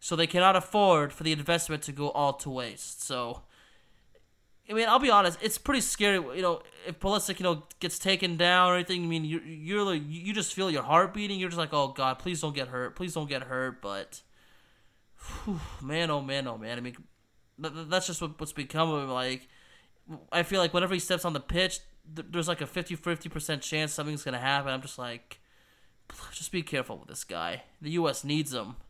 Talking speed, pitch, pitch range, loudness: 215 wpm, 160 Hz, 140-180 Hz, -29 LUFS